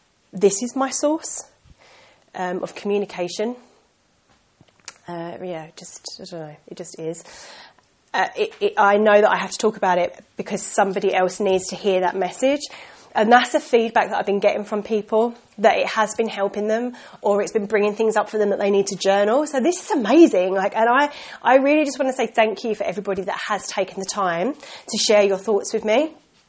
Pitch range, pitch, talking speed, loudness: 195-240 Hz, 210 Hz, 210 wpm, -20 LUFS